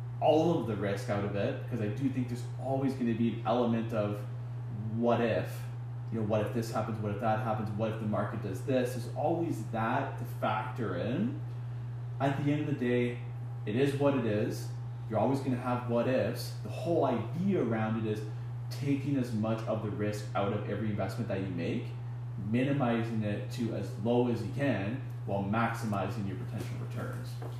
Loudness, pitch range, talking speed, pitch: -33 LUFS, 110-125 Hz, 200 wpm, 120 Hz